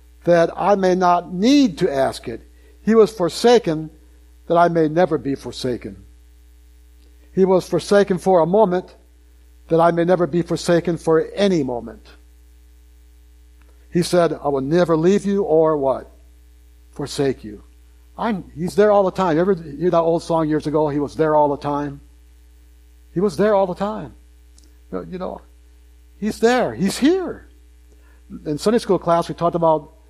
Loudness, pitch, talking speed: -18 LUFS, 155 Hz, 165 wpm